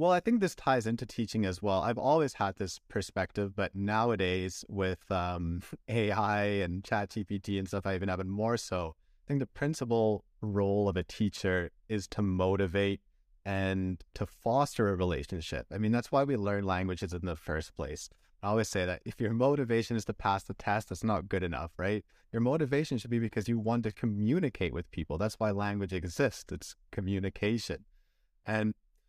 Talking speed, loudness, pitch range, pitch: 190 wpm, -32 LUFS, 95-115 Hz, 100 Hz